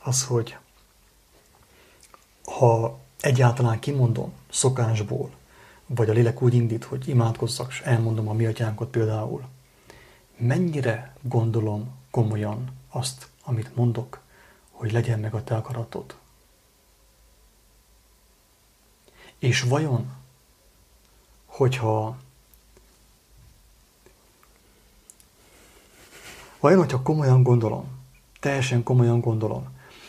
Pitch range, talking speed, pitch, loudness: 110-130 Hz, 80 wpm, 120 Hz, -24 LUFS